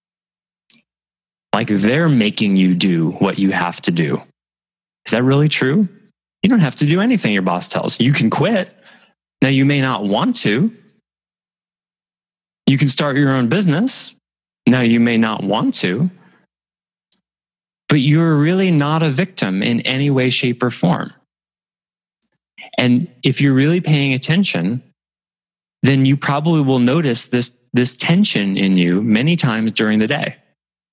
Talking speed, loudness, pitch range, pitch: 150 wpm, -15 LUFS, 110-165 Hz, 135 Hz